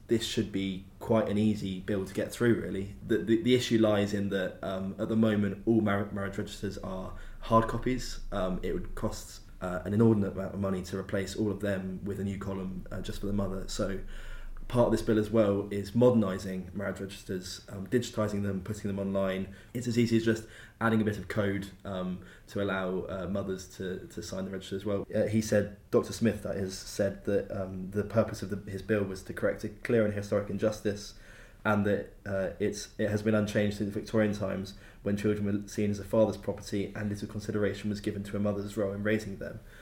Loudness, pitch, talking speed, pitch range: -31 LUFS, 100 Hz, 225 wpm, 95-110 Hz